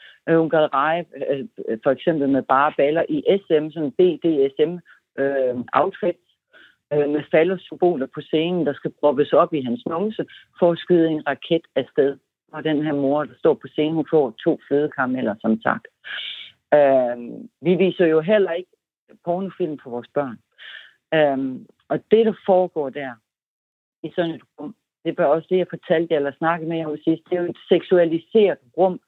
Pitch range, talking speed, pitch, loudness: 145-175 Hz, 170 wpm, 160 Hz, -21 LUFS